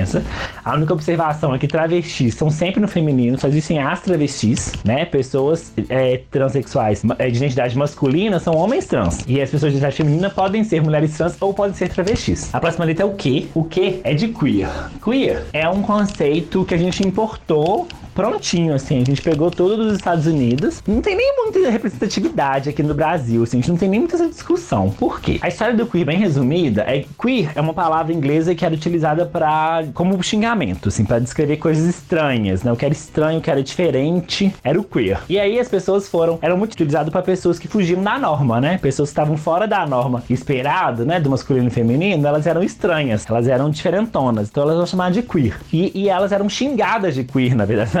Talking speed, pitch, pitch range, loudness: 215 wpm, 160 Hz, 140-185 Hz, -18 LUFS